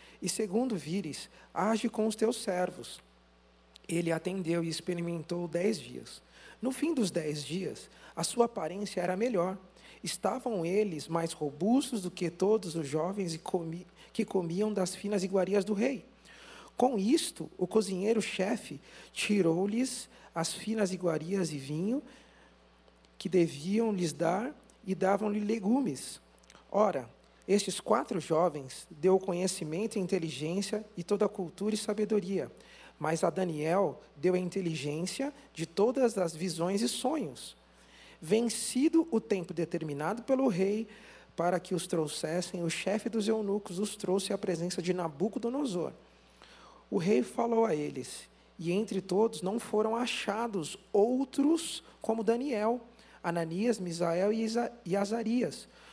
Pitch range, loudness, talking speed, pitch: 170-220 Hz, -32 LUFS, 130 wpm, 190 Hz